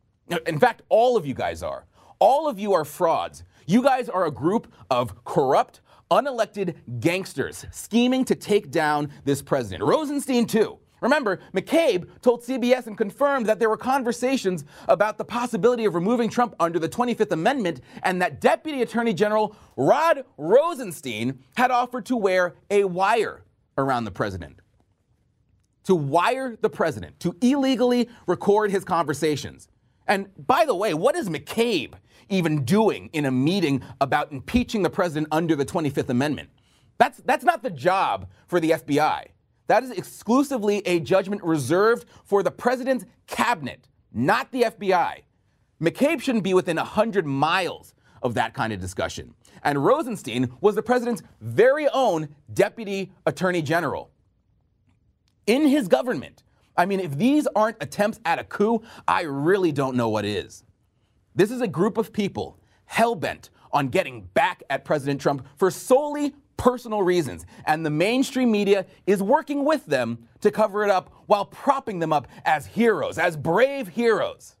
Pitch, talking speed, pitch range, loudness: 195 Hz, 155 wpm, 155-240 Hz, -23 LUFS